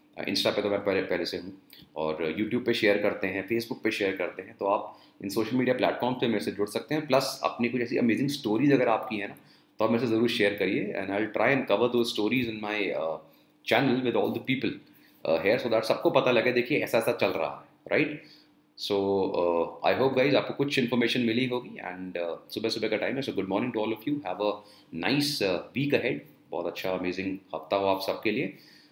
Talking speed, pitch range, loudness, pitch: 235 wpm, 100-125 Hz, -28 LUFS, 110 Hz